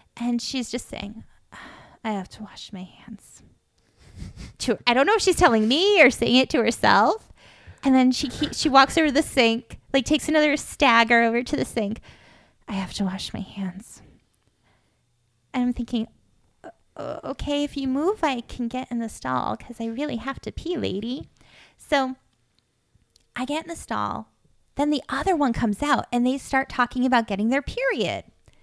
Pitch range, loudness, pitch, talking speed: 210-285 Hz, -23 LUFS, 245 Hz, 185 wpm